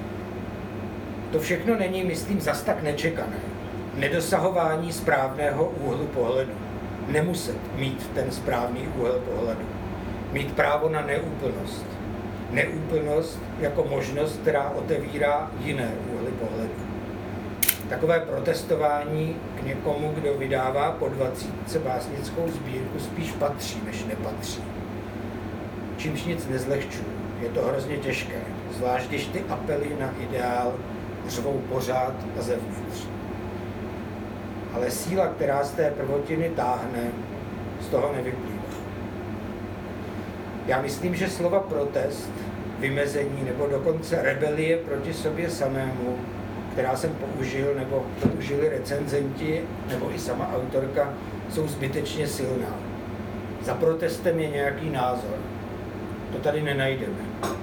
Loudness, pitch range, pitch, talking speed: -28 LUFS, 110-145 Hz, 125 Hz, 105 wpm